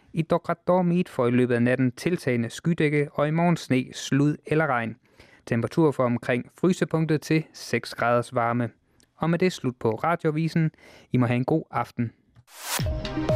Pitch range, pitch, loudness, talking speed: 120-160 Hz, 140 Hz, -25 LUFS, 160 wpm